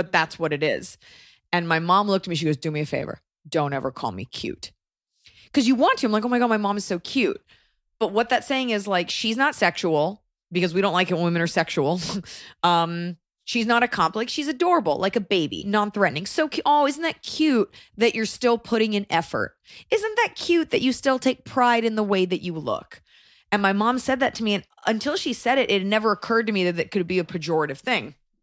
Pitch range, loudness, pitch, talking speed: 175-245 Hz, -23 LUFS, 210 Hz, 245 wpm